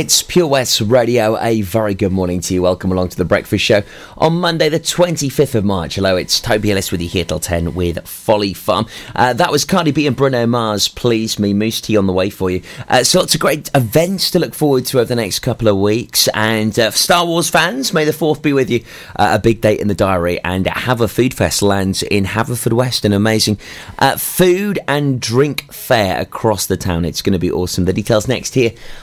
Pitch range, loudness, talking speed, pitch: 95-140 Hz, -15 LUFS, 230 wpm, 110 Hz